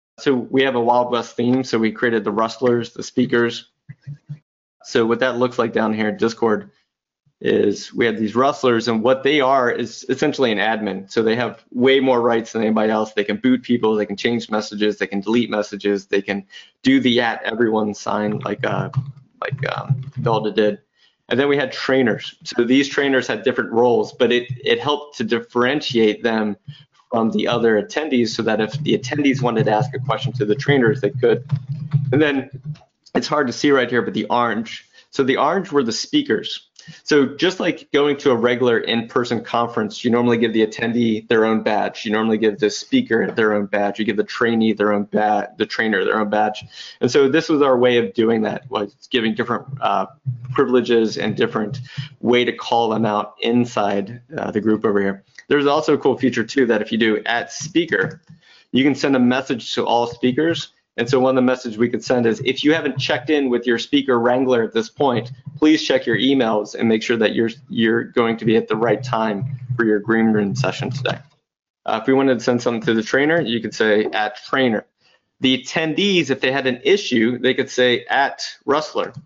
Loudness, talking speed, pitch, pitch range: -19 LUFS, 210 wpm, 120 Hz, 110-135 Hz